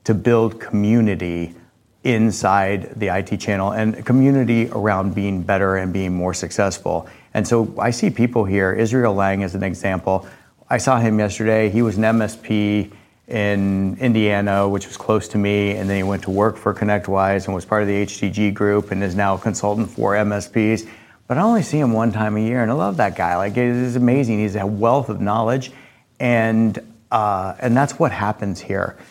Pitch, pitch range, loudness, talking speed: 105 Hz, 100-115 Hz, -19 LUFS, 190 wpm